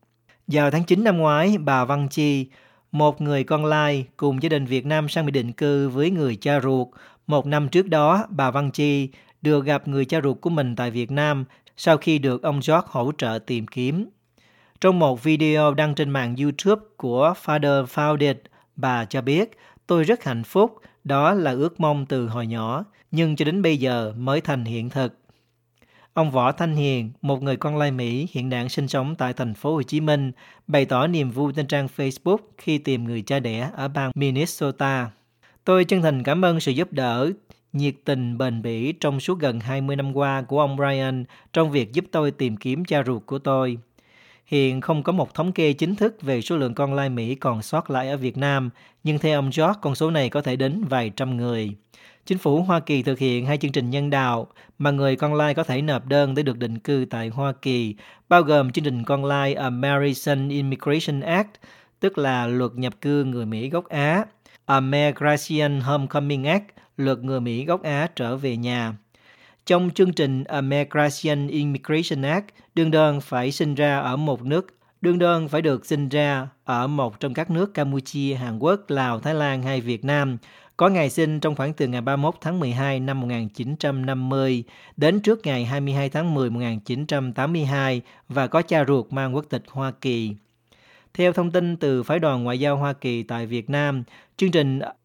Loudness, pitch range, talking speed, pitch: -23 LUFS, 130-155 Hz, 200 wpm, 140 Hz